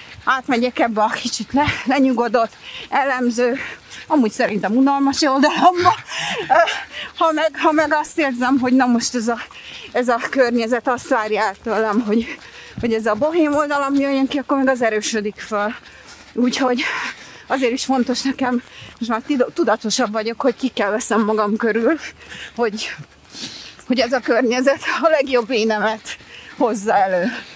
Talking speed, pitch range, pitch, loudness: 145 wpm, 225-275 Hz, 250 Hz, -18 LUFS